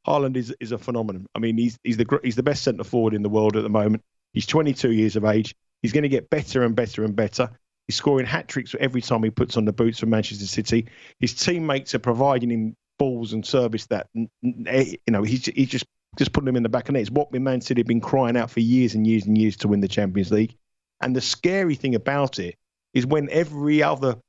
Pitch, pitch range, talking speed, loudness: 120 Hz, 110-135 Hz, 245 wpm, -23 LUFS